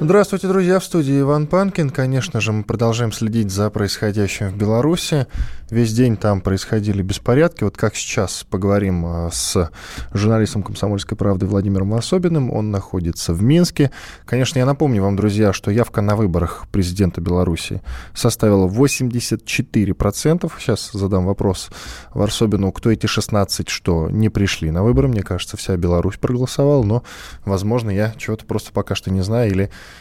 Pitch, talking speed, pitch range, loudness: 105 Hz, 150 wpm, 95-120 Hz, -18 LUFS